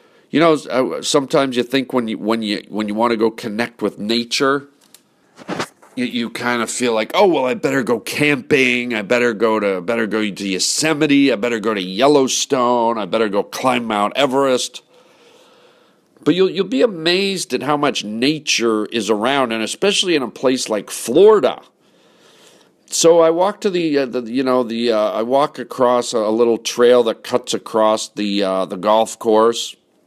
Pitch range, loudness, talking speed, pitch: 110-140 Hz, -17 LUFS, 185 wpm, 120 Hz